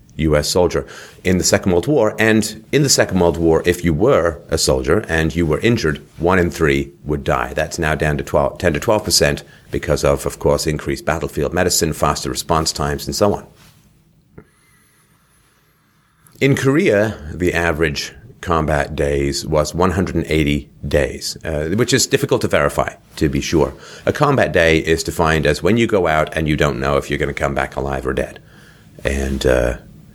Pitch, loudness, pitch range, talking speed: 80 Hz, -17 LUFS, 75-90 Hz, 195 wpm